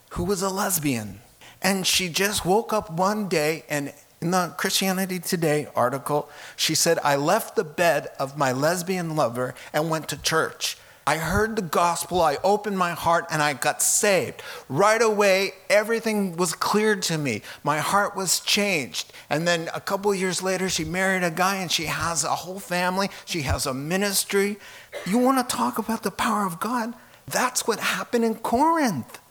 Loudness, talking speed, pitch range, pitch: -23 LUFS, 180 wpm, 155-205 Hz, 185 Hz